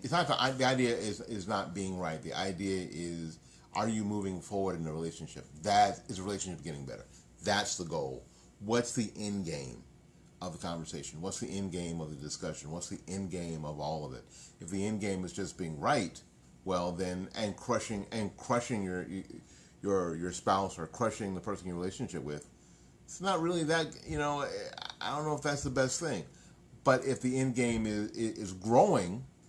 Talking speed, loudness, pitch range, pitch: 200 wpm, -34 LUFS, 85-120 Hz, 95 Hz